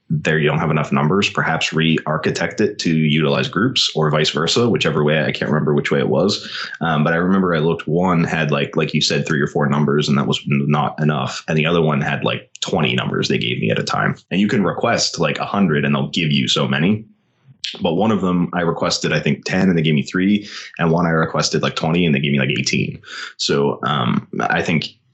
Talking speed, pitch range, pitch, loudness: 245 wpm, 75-85 Hz, 80 Hz, -18 LUFS